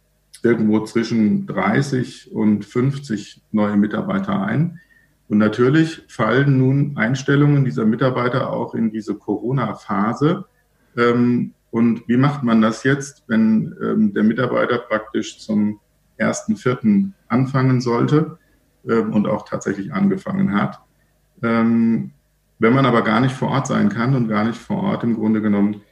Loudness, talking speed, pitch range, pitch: -19 LUFS, 130 wpm, 110-150 Hz, 125 Hz